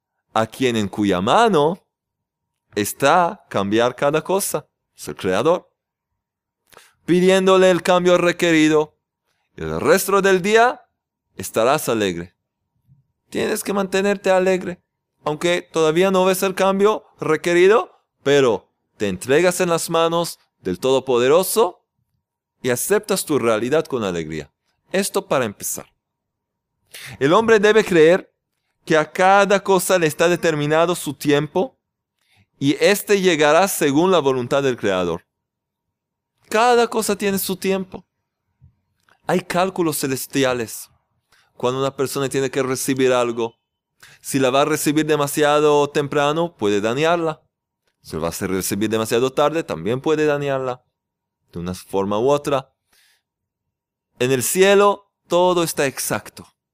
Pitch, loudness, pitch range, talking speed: 155 Hz, -18 LUFS, 130-185 Hz, 125 wpm